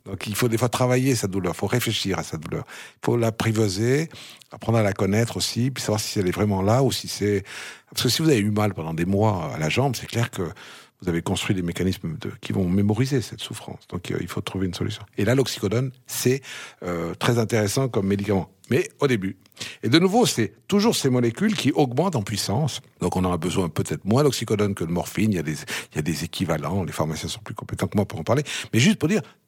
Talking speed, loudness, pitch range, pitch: 250 wpm, -24 LUFS, 95-125 Hz, 105 Hz